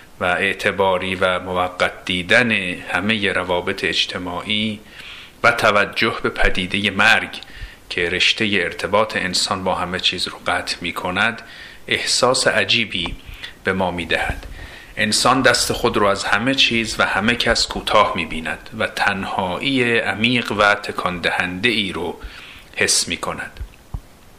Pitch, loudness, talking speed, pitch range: 105 Hz, -18 LUFS, 135 wpm, 95-115 Hz